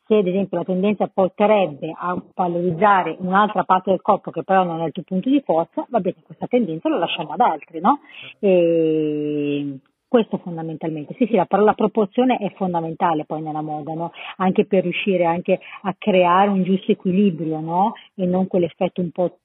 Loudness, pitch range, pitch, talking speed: -20 LUFS, 165-195 Hz, 185 Hz, 180 wpm